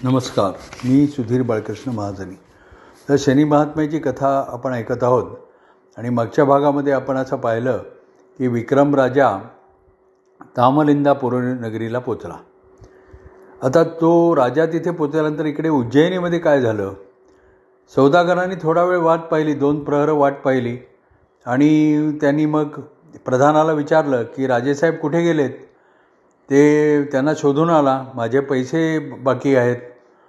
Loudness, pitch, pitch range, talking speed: -18 LUFS, 140 Hz, 125-155 Hz, 115 wpm